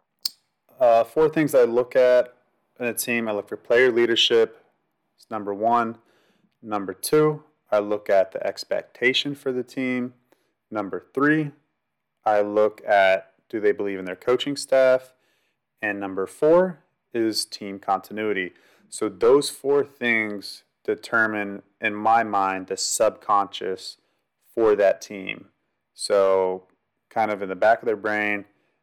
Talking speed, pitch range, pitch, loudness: 140 wpm, 105-135 Hz, 115 Hz, -23 LUFS